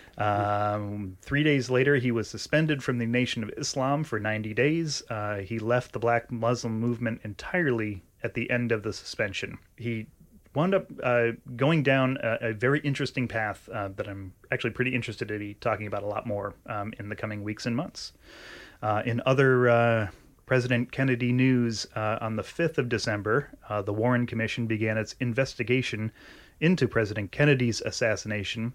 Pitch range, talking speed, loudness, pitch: 105-130 Hz, 175 wpm, -28 LUFS, 115 Hz